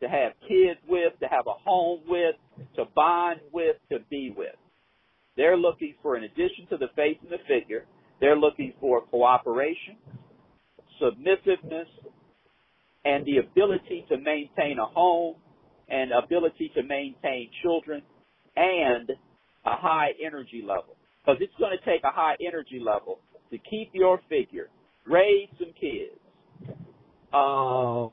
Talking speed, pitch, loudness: 140 wpm, 175 Hz, -26 LUFS